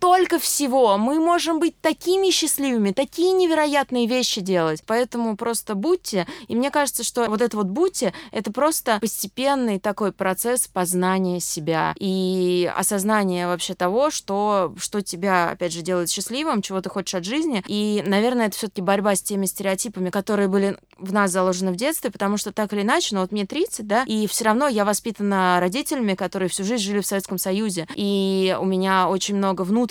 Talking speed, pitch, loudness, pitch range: 180 wpm, 205 Hz, -22 LUFS, 190-245 Hz